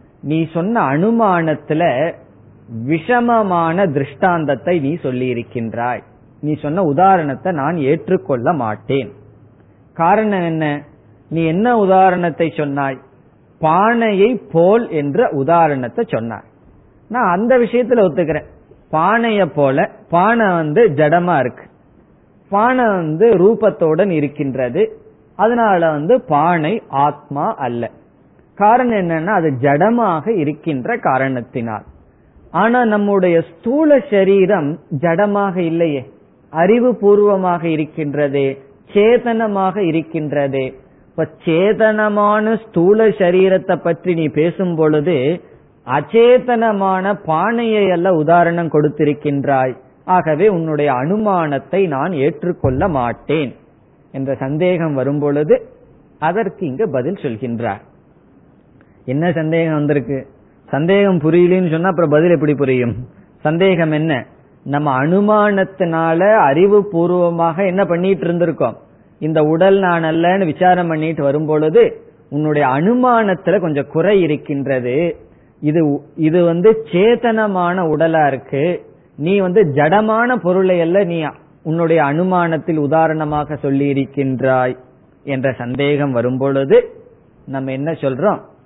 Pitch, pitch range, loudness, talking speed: 165 Hz, 140-195 Hz, -15 LUFS, 95 wpm